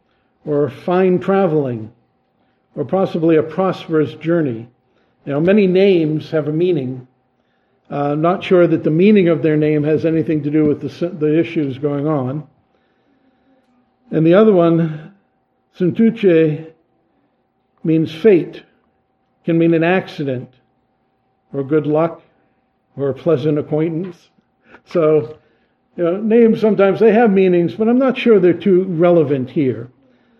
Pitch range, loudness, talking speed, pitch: 145-185 Hz, -15 LUFS, 135 wpm, 160 Hz